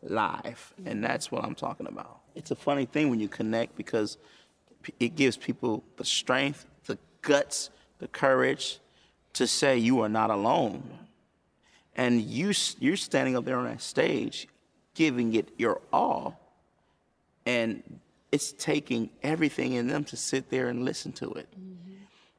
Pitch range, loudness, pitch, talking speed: 120-150 Hz, -29 LUFS, 130 Hz, 150 wpm